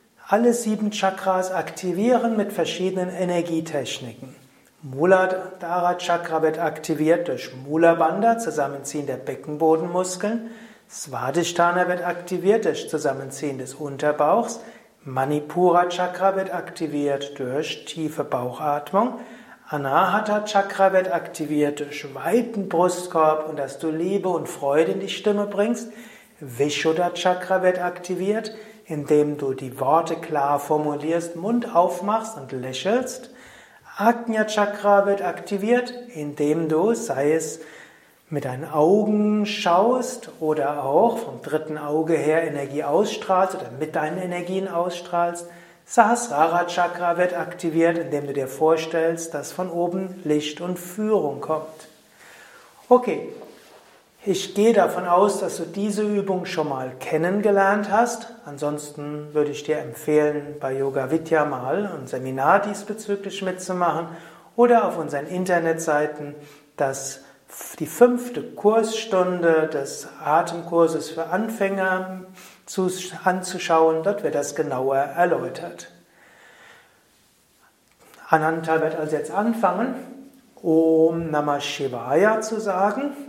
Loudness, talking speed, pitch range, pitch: -22 LUFS, 110 wpm, 150-200 Hz, 175 Hz